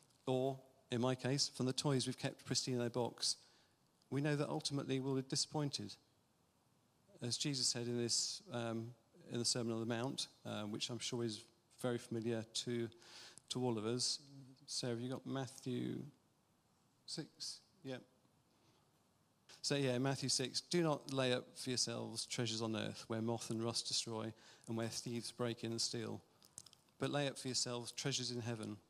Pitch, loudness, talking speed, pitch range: 125 Hz, -41 LUFS, 175 wpm, 115-135 Hz